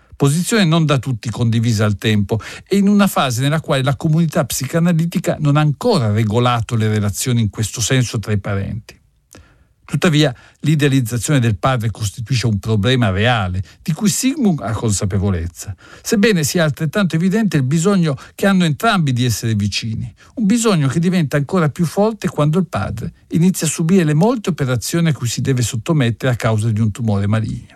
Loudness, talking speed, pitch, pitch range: -17 LUFS, 175 wpm, 135 Hz, 115-170 Hz